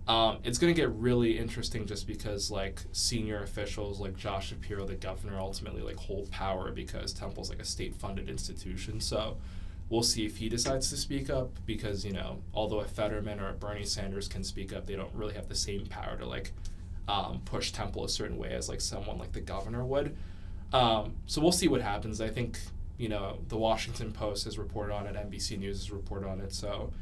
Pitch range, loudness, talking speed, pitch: 95-110 Hz, -34 LUFS, 210 wpm, 100 Hz